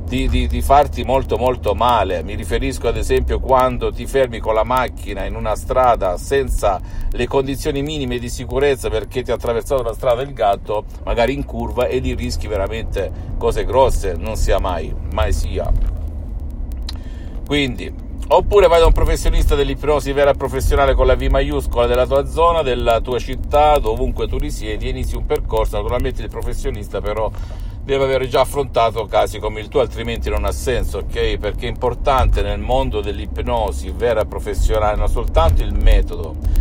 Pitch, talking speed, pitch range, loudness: 105 Hz, 170 wpm, 80-130 Hz, -19 LUFS